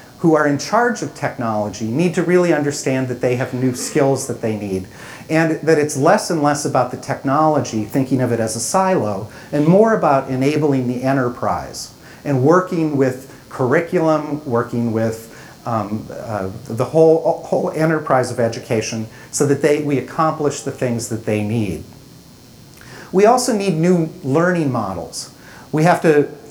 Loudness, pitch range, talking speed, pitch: -18 LUFS, 120-160 Hz, 165 wpm, 135 Hz